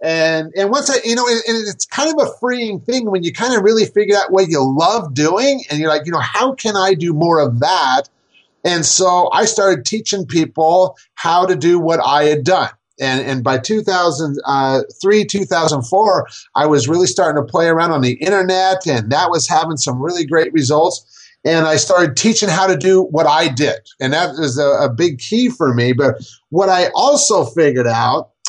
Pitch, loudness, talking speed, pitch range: 170 Hz, -14 LUFS, 205 wpm, 150-200 Hz